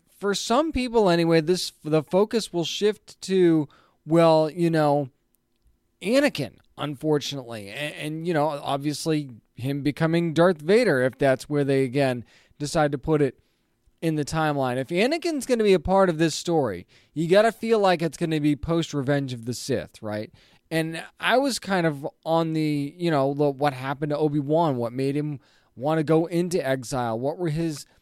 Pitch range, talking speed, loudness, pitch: 135-170 Hz, 185 wpm, -24 LUFS, 155 Hz